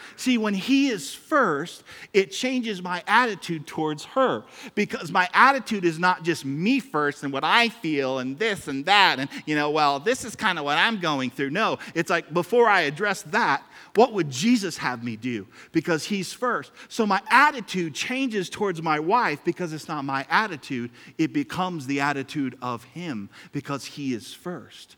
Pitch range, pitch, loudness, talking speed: 140-210 Hz, 170 Hz, -24 LUFS, 185 wpm